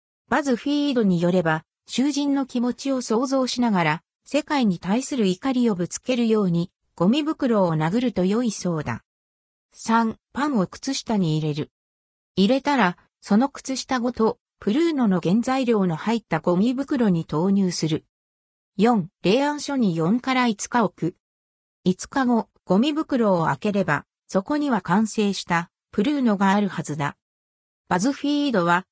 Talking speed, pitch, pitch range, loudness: 280 characters per minute, 210 Hz, 170-255 Hz, -23 LUFS